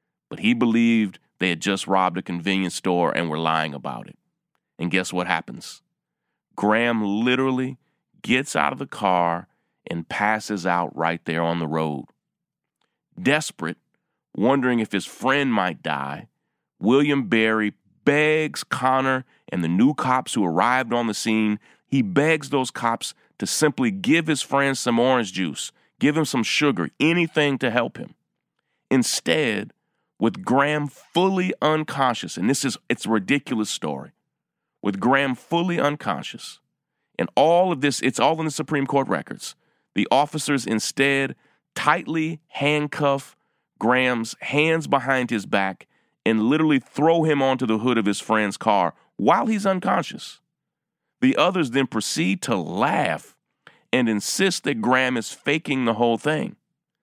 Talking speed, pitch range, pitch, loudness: 145 wpm, 105-150 Hz, 130 Hz, -22 LUFS